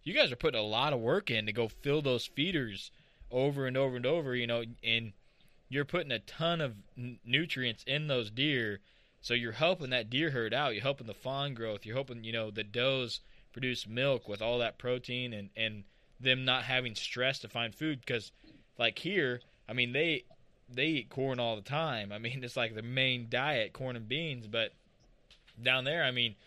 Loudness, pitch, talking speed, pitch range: -33 LUFS, 125 Hz, 210 wpm, 115-135 Hz